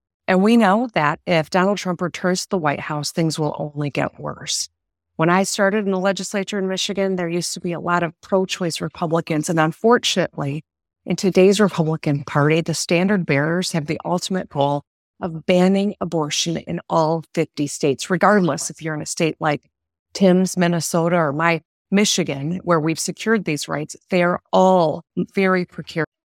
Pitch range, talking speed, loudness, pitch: 155-185 Hz, 175 wpm, -20 LUFS, 170 Hz